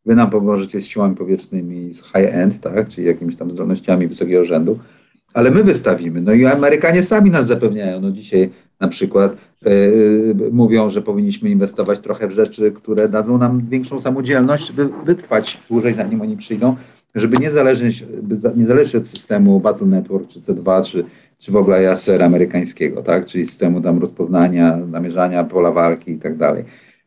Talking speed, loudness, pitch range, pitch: 160 wpm, -15 LUFS, 95-140 Hz, 110 Hz